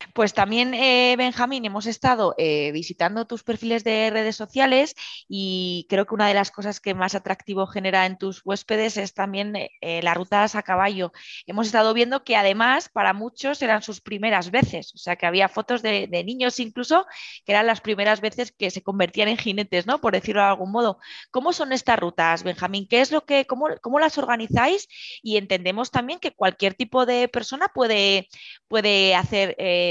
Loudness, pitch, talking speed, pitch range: -22 LUFS, 215 Hz, 190 wpm, 195-245 Hz